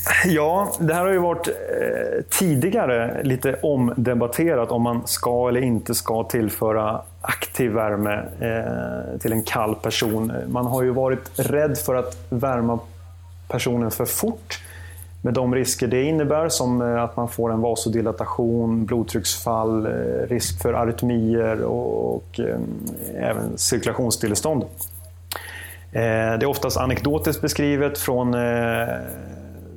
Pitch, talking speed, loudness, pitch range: 115 Hz, 115 wpm, -22 LUFS, 105-125 Hz